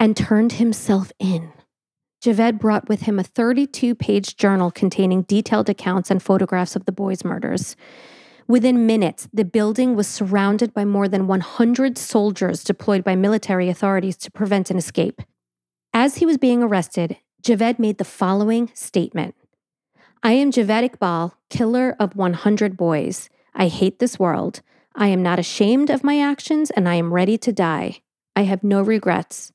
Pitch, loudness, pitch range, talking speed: 205 Hz, -19 LUFS, 190-235 Hz, 160 wpm